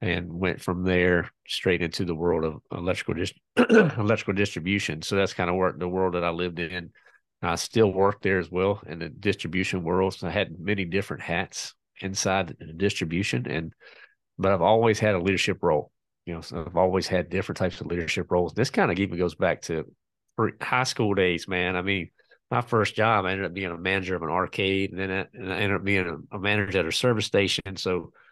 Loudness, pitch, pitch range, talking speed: -26 LUFS, 95 Hz, 90-100 Hz, 220 wpm